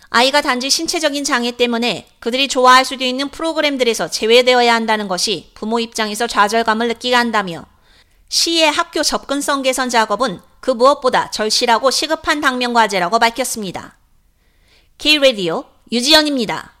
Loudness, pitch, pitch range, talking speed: -15 LUFS, 250 Hz, 225-275 Hz, 365 characters per minute